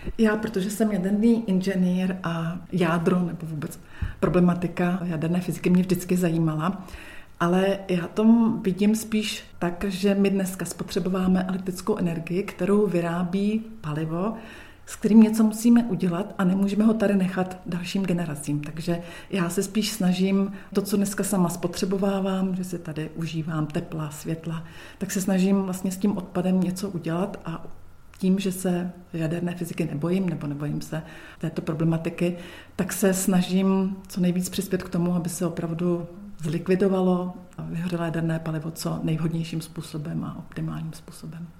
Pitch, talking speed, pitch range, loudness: 180 Hz, 145 wpm, 170-195 Hz, -25 LUFS